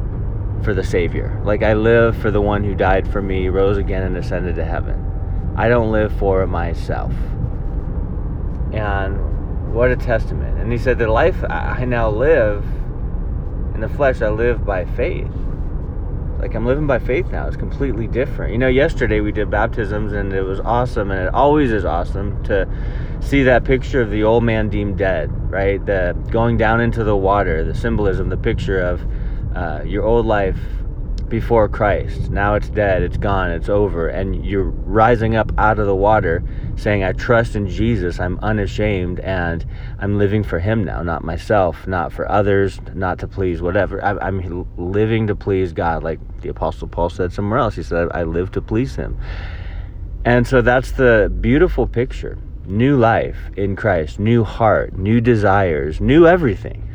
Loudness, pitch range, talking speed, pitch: -18 LUFS, 90-110 Hz, 175 wpm, 100 Hz